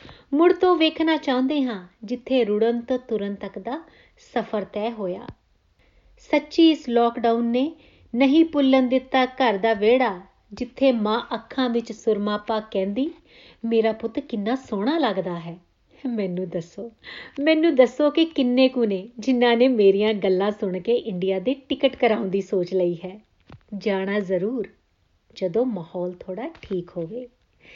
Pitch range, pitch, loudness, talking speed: 200-260 Hz, 230 Hz, -22 LUFS, 140 wpm